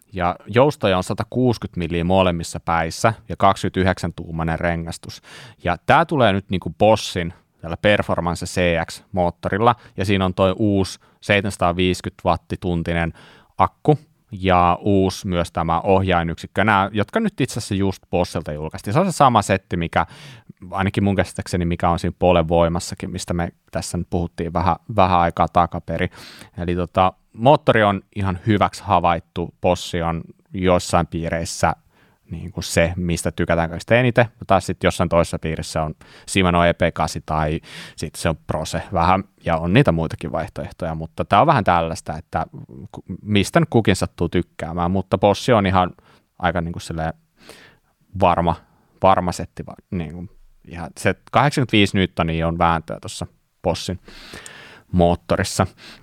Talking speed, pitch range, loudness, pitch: 140 wpm, 85-100 Hz, -20 LUFS, 90 Hz